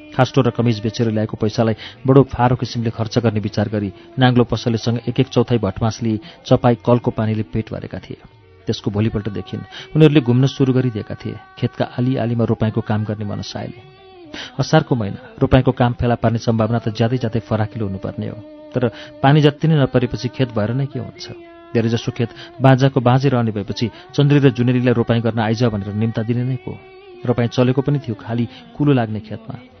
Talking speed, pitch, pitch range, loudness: 180 wpm, 120 Hz, 110-130 Hz, -18 LUFS